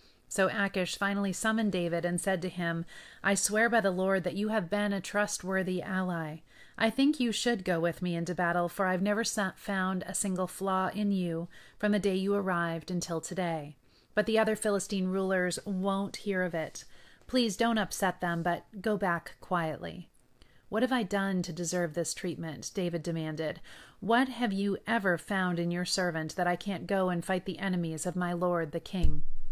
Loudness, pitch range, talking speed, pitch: -31 LUFS, 175-205 Hz, 190 wpm, 185 Hz